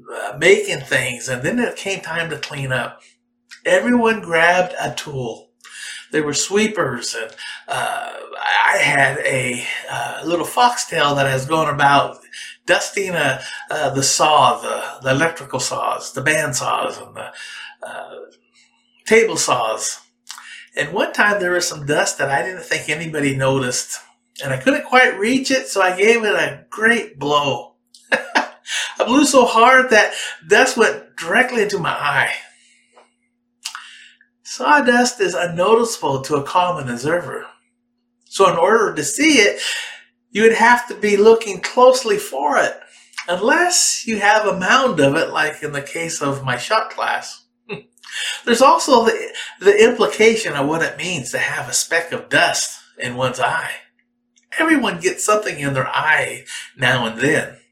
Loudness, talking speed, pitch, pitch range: -17 LUFS, 155 wpm, 210 Hz, 150-240 Hz